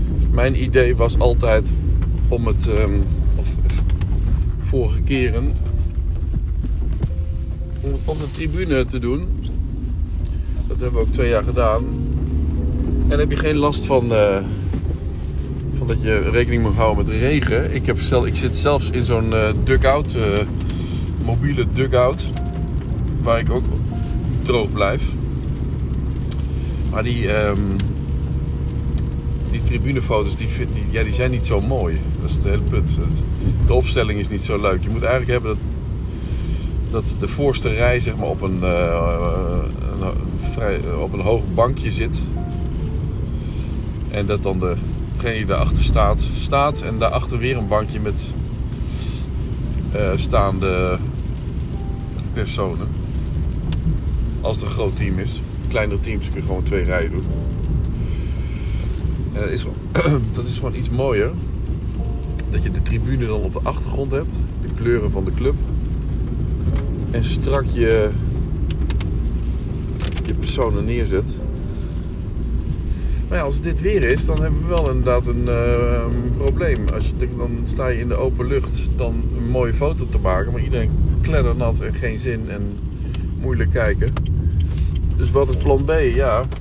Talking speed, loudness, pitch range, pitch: 140 wpm, -21 LUFS, 75-105 Hz, 85 Hz